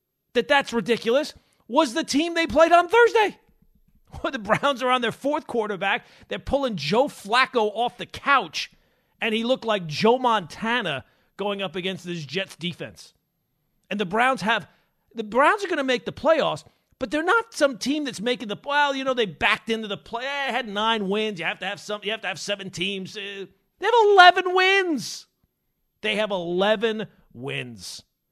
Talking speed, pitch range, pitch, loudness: 185 wpm, 195-275 Hz, 225 Hz, -23 LUFS